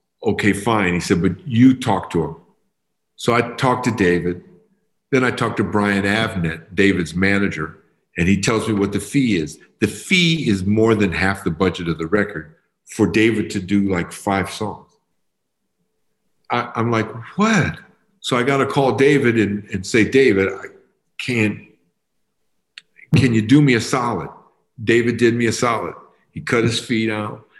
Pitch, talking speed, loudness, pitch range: 110 Hz, 175 wpm, -18 LUFS, 100-120 Hz